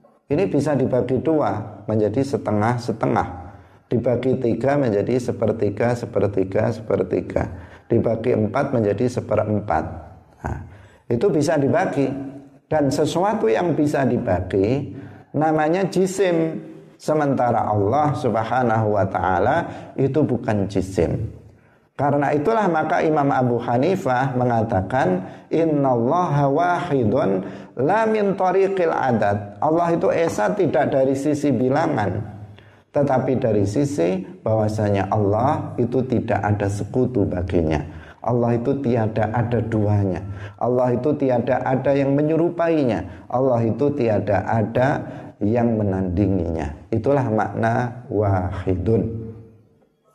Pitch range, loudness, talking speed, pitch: 105-140 Hz, -21 LUFS, 100 wpm, 120 Hz